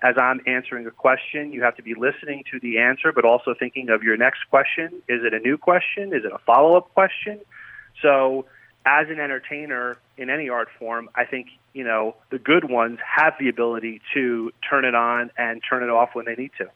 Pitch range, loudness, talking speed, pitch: 120-145 Hz, -21 LUFS, 220 wpm, 125 Hz